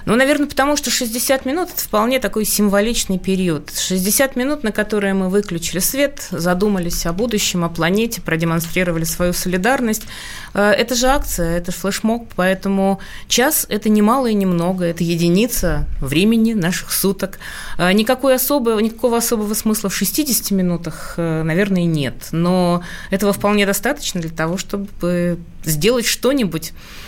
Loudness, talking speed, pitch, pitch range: -17 LUFS, 140 wpm, 200 Hz, 175-230 Hz